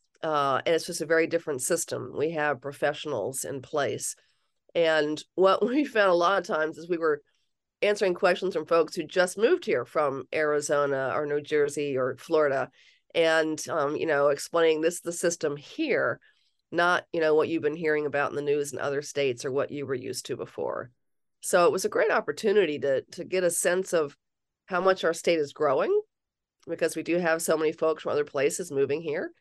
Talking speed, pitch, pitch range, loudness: 205 wpm, 165 Hz, 150-190 Hz, -27 LUFS